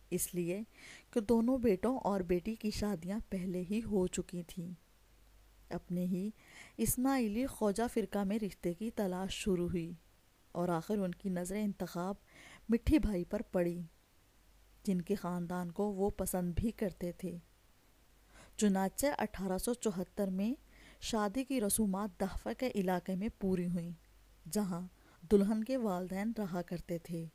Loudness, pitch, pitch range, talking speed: -36 LUFS, 190 Hz, 175-215 Hz, 145 wpm